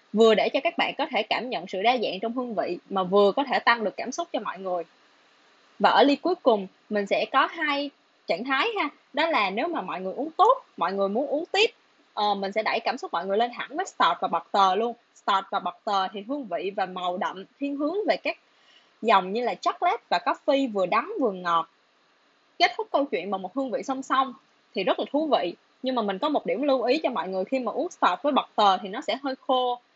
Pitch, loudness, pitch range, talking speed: 255 Hz, -25 LUFS, 200-300 Hz, 255 wpm